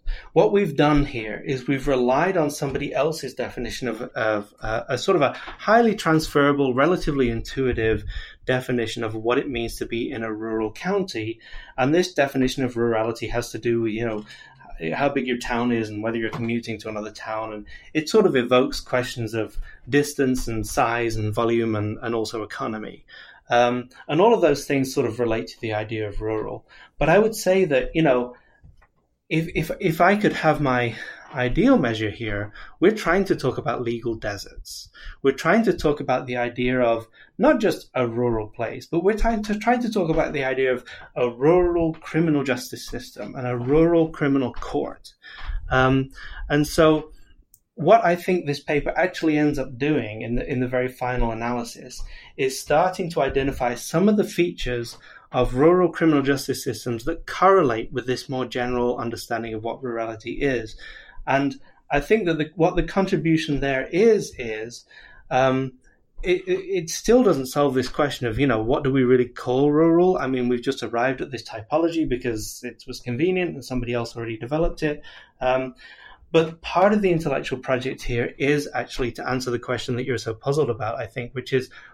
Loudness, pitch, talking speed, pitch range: -23 LUFS, 130 Hz, 185 wpm, 120-160 Hz